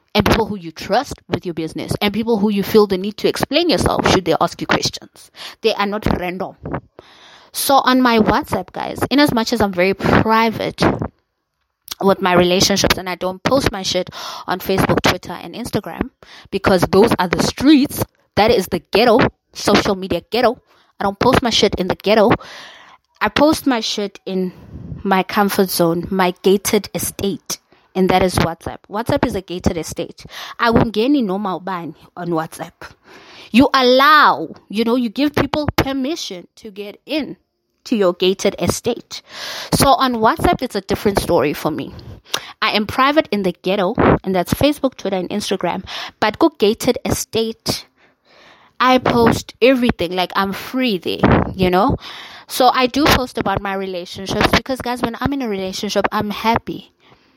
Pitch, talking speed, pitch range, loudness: 205 Hz, 175 wpm, 185-240 Hz, -17 LUFS